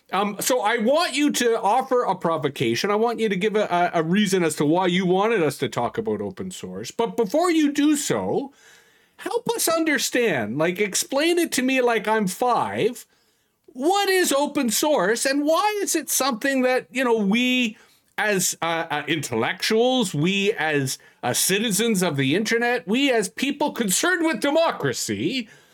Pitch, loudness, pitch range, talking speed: 230 Hz, -22 LUFS, 190-280 Hz, 175 wpm